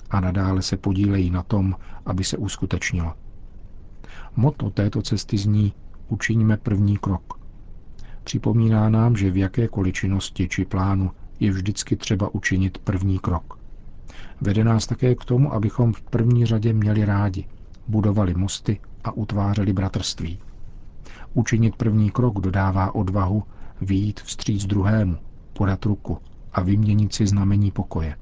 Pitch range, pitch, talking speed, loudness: 95-110 Hz, 100 Hz, 130 wpm, -22 LUFS